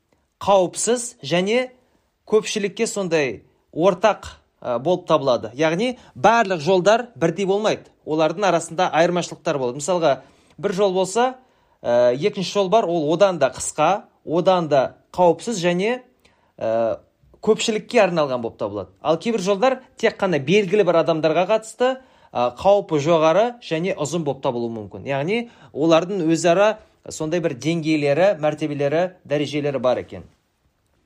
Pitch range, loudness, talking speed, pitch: 155-210 Hz, -20 LUFS, 120 wpm, 175 Hz